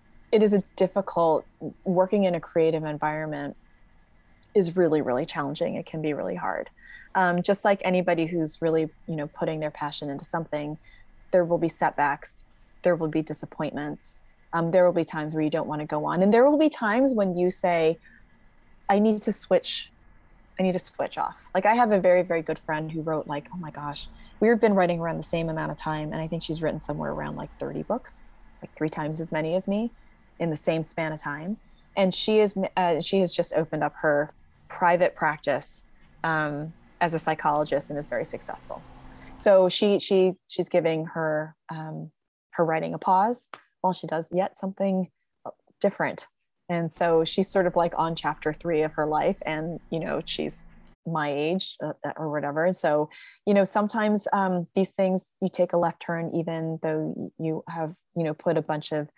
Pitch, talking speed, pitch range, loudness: 165 Hz, 195 wpm, 155-185 Hz, -26 LUFS